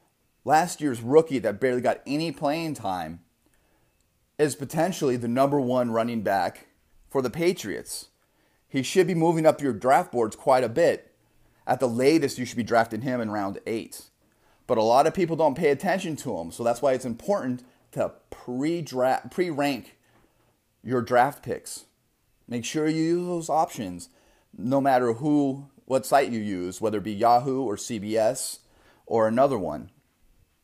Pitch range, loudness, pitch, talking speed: 115-150 Hz, -25 LUFS, 130 Hz, 165 wpm